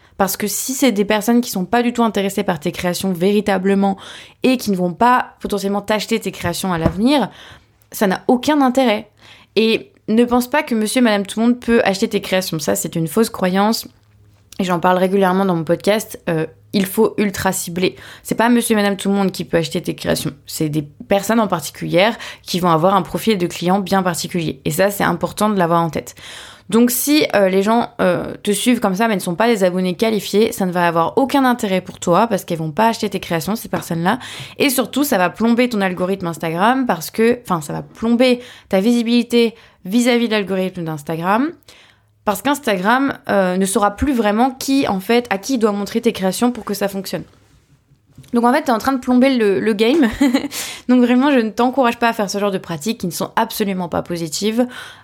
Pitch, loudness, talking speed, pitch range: 205 Hz, -17 LUFS, 220 wpm, 180-235 Hz